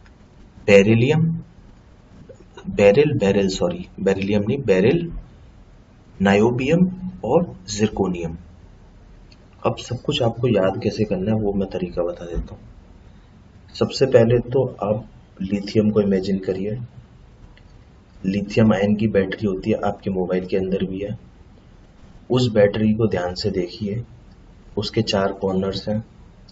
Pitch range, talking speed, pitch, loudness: 95-115 Hz, 120 wpm, 100 Hz, -20 LUFS